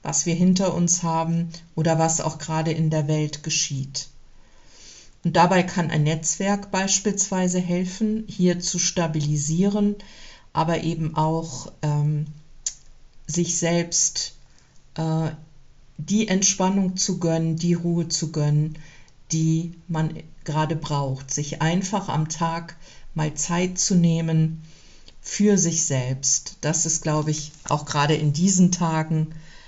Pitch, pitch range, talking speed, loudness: 160 Hz, 155-175 Hz, 125 wpm, -23 LUFS